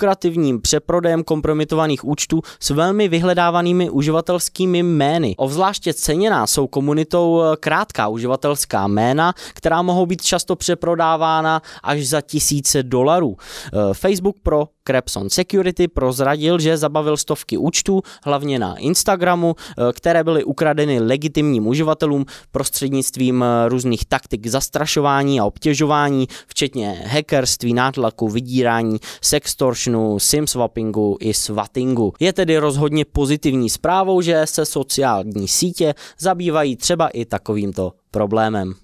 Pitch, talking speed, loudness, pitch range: 150 Hz, 105 wpm, -18 LUFS, 125-165 Hz